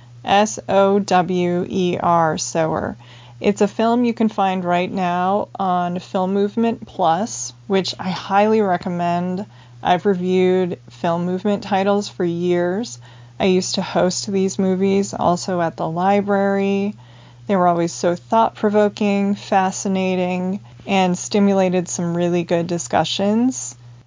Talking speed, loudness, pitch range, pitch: 130 wpm, -19 LUFS, 175-200 Hz, 185 Hz